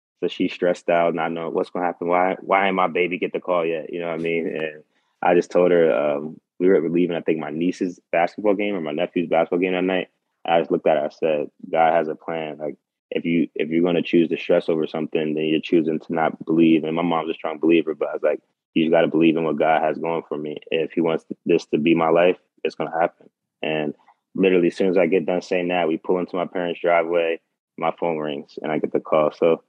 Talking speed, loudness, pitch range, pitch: 265 wpm, -21 LUFS, 80-90 Hz, 85 Hz